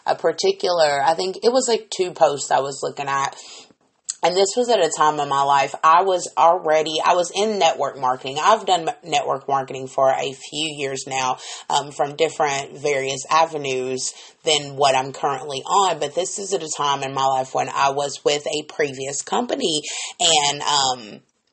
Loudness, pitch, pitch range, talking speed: -20 LUFS, 145 Hz, 135-170 Hz, 185 wpm